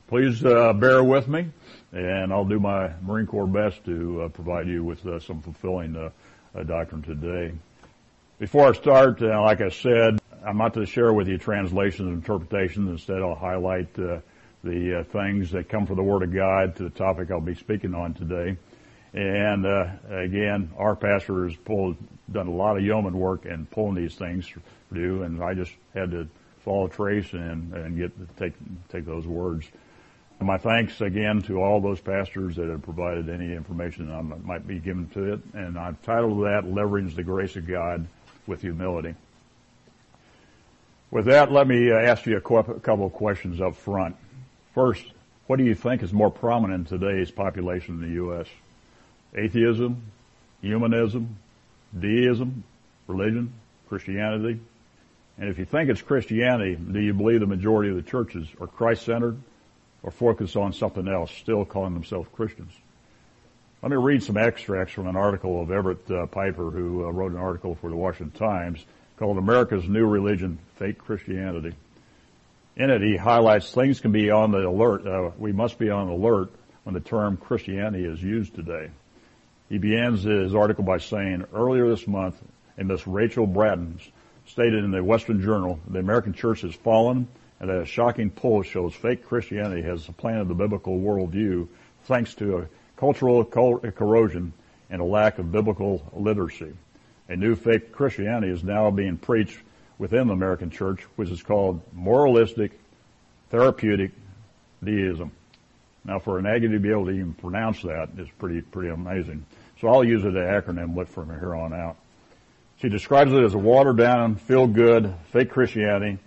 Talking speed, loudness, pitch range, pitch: 170 wpm, -24 LUFS, 90-110 Hz, 100 Hz